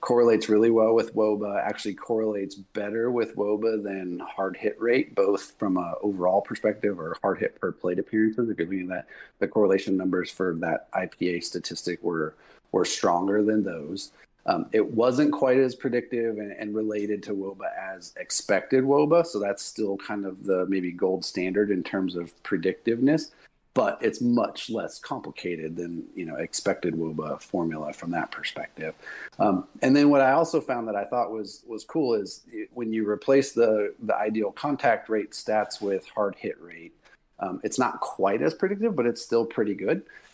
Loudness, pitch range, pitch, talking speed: -26 LUFS, 95-120 Hz, 105 Hz, 180 wpm